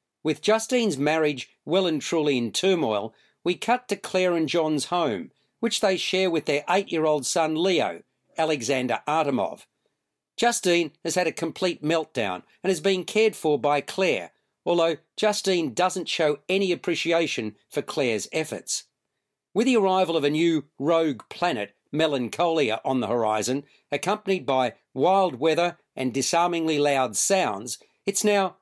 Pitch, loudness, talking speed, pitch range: 165 Hz, -24 LUFS, 150 wpm, 145-185 Hz